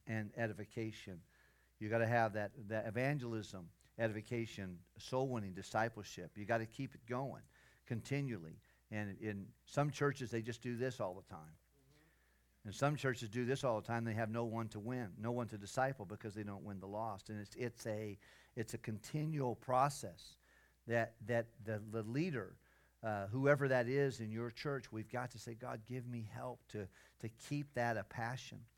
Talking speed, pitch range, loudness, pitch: 185 wpm, 105-125 Hz, -42 LUFS, 115 Hz